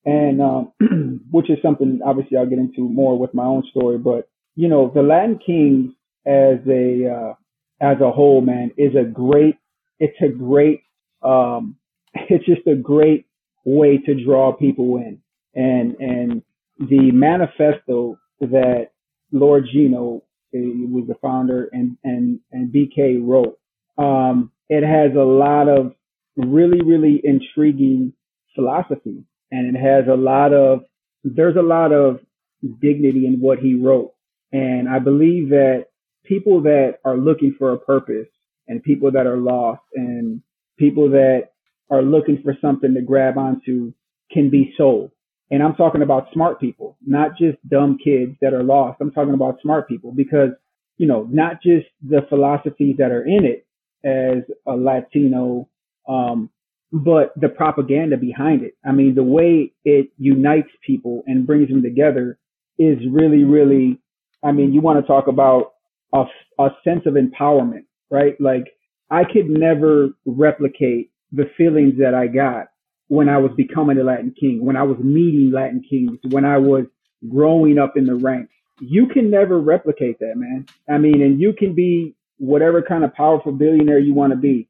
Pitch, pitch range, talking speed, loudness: 140 Hz, 130-150 Hz, 165 wpm, -16 LUFS